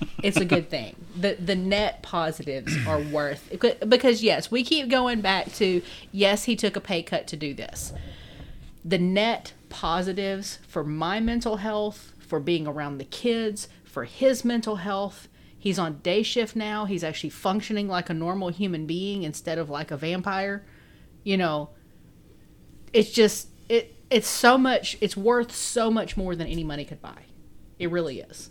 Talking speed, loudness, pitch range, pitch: 170 wpm, -26 LUFS, 160-215 Hz, 190 Hz